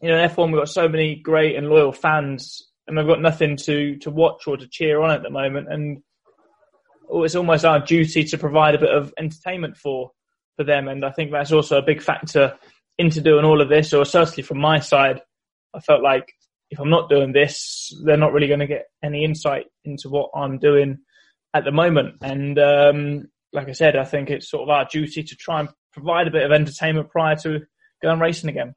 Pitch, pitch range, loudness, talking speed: 150 Hz, 145-160 Hz, -19 LUFS, 220 wpm